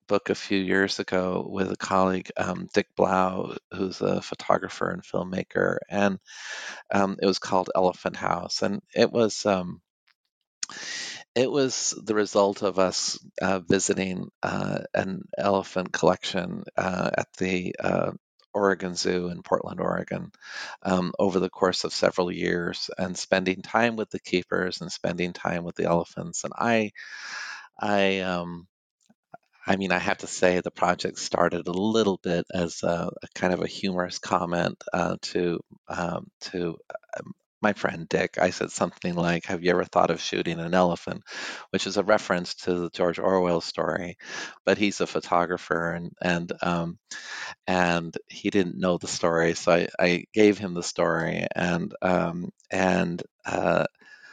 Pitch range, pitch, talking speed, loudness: 85-100 Hz, 95 Hz, 160 wpm, -26 LUFS